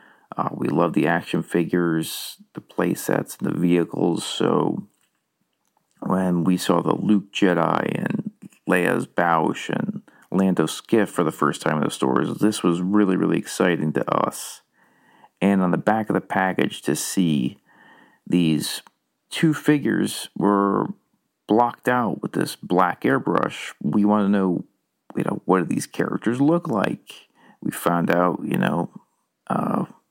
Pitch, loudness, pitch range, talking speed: 95 Hz, -22 LUFS, 85-105 Hz, 150 wpm